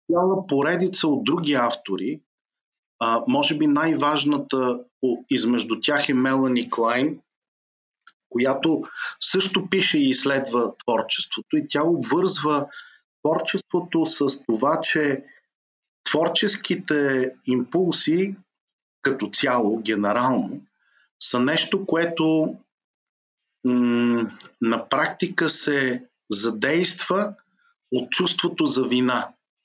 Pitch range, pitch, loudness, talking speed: 125-180 Hz, 150 Hz, -22 LUFS, 90 wpm